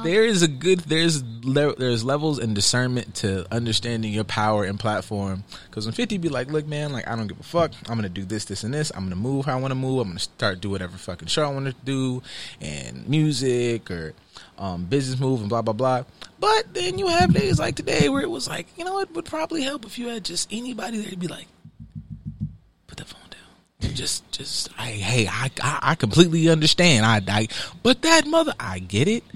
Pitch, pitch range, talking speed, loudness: 130 Hz, 105-170 Hz, 225 wpm, -23 LUFS